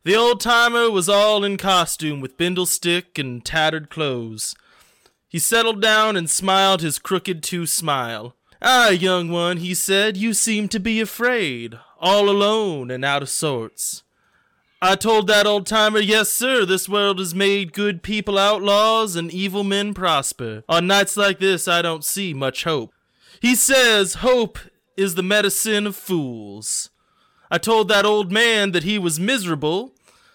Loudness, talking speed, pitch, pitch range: -18 LUFS, 160 wpm, 195 Hz, 170-210 Hz